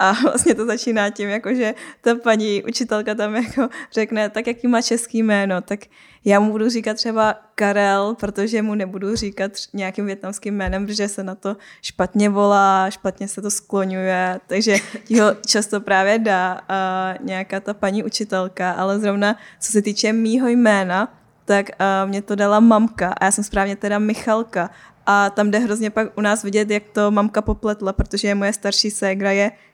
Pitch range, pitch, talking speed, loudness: 195-220 Hz, 205 Hz, 180 wpm, -19 LUFS